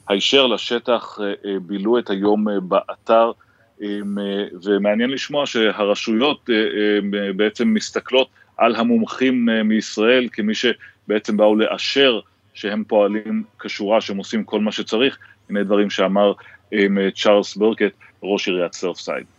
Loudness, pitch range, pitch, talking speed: -19 LUFS, 100-115 Hz, 105 Hz, 105 wpm